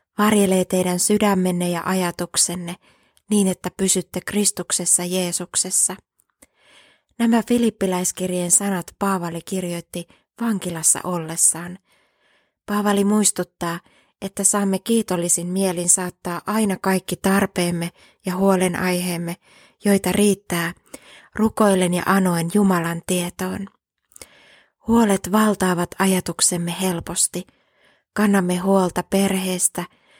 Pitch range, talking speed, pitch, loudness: 175-200 Hz, 85 wpm, 185 Hz, -20 LUFS